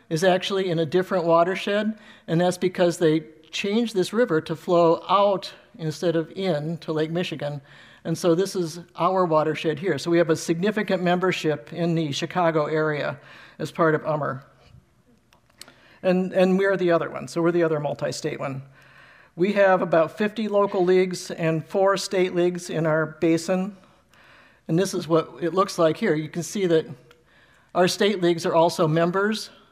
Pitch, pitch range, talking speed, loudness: 170 Hz, 160-185 Hz, 175 wpm, -23 LUFS